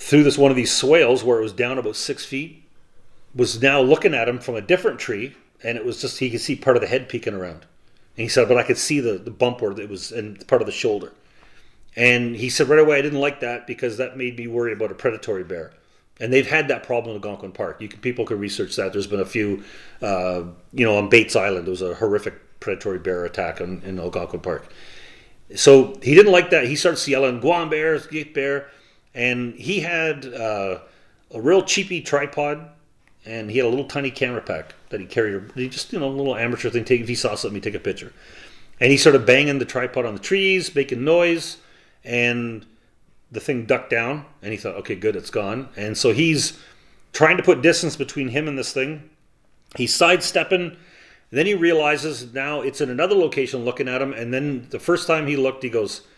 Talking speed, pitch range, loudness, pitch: 225 wpm, 120-155 Hz, -20 LUFS, 135 Hz